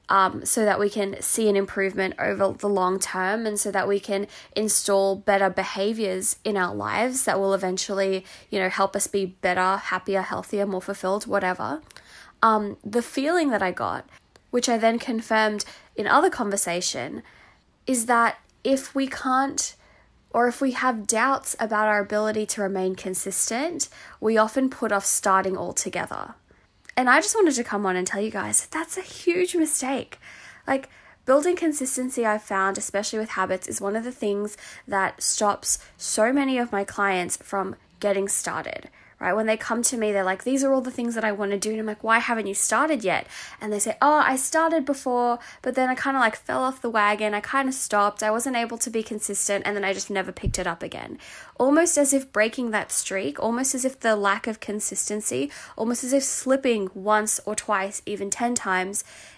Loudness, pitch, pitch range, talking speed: -24 LUFS, 215 Hz, 195-250 Hz, 195 wpm